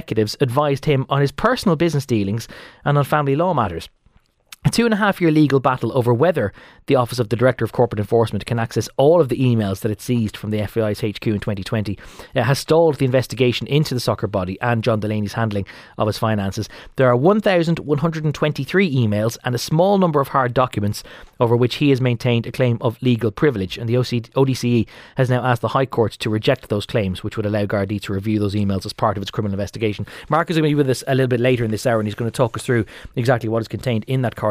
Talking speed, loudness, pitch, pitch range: 240 wpm, -19 LUFS, 120 Hz, 110-135 Hz